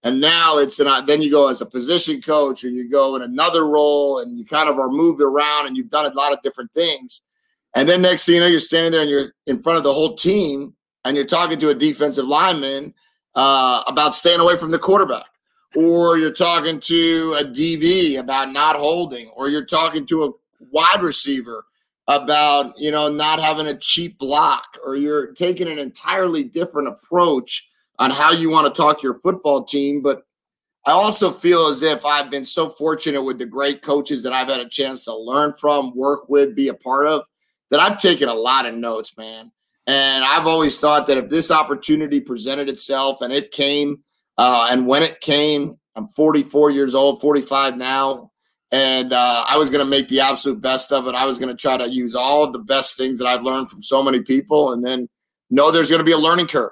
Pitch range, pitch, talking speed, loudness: 135-160 Hz, 145 Hz, 215 wpm, -17 LUFS